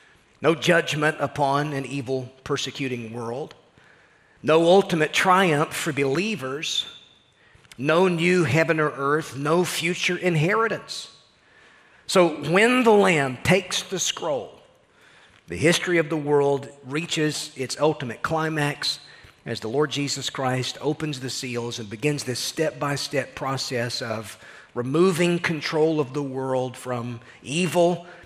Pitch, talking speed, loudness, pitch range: 150 Hz, 125 wpm, -23 LUFS, 130-170 Hz